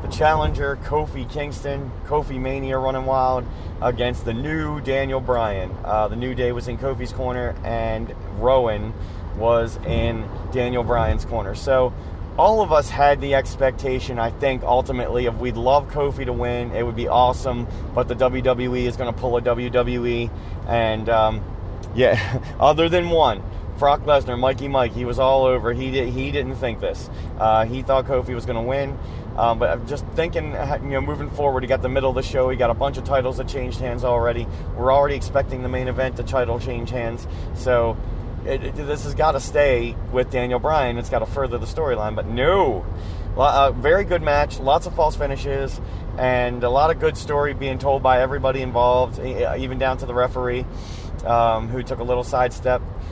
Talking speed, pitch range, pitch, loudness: 190 wpm, 115-130 Hz, 125 Hz, -21 LUFS